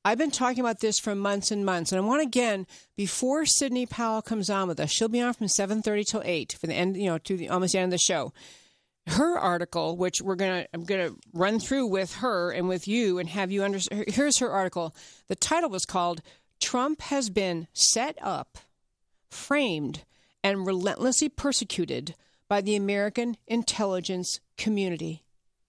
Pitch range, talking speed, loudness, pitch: 180-235 Hz, 185 wpm, -27 LUFS, 200 Hz